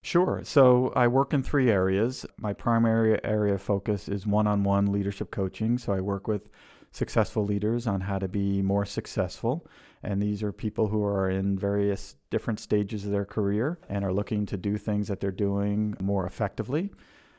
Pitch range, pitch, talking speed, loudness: 100-110 Hz, 105 Hz, 185 wpm, -27 LUFS